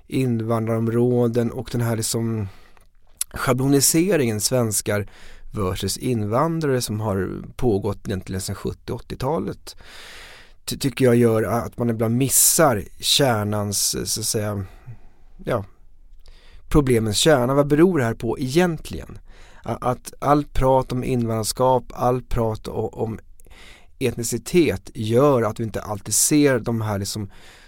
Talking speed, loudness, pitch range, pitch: 120 wpm, -21 LUFS, 100-125 Hz, 115 Hz